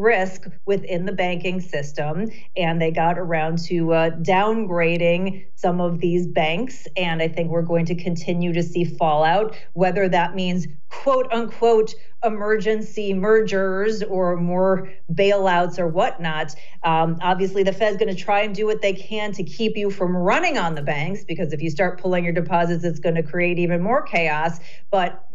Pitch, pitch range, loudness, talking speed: 180 Hz, 170-200 Hz, -21 LUFS, 175 wpm